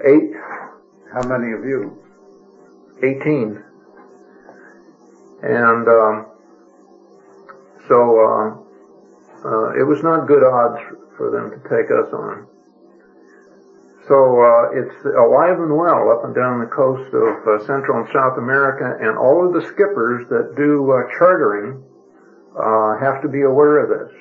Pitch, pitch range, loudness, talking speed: 125 Hz, 110-145 Hz, -16 LUFS, 135 wpm